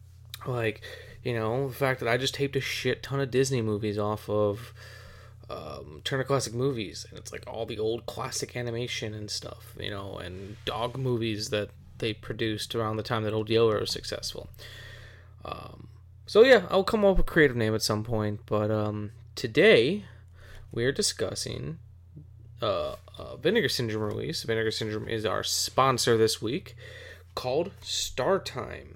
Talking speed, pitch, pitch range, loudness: 170 wpm, 110 Hz, 105-125 Hz, -28 LUFS